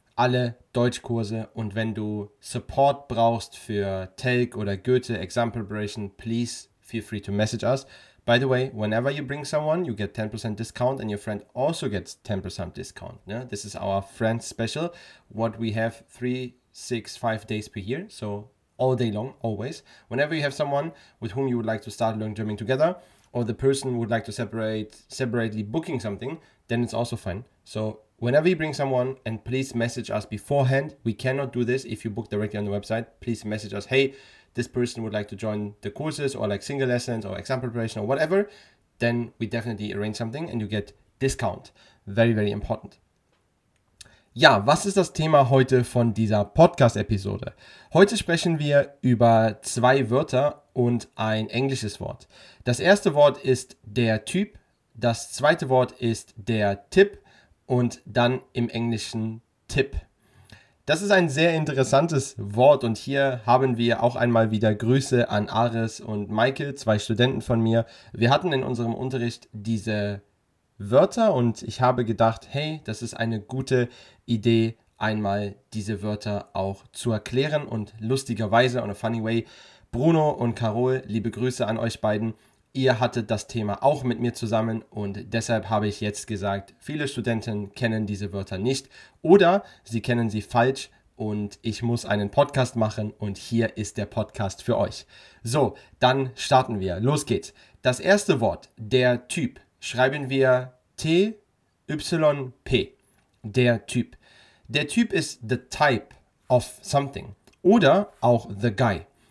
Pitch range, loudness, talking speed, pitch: 110-130 Hz, -25 LUFS, 165 wpm, 115 Hz